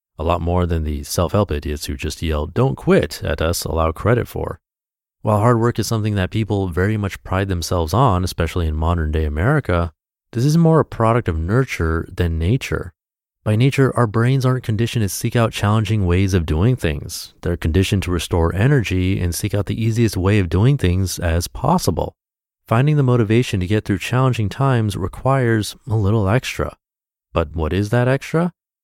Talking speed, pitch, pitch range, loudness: 185 wpm, 100 Hz, 85-120 Hz, -19 LUFS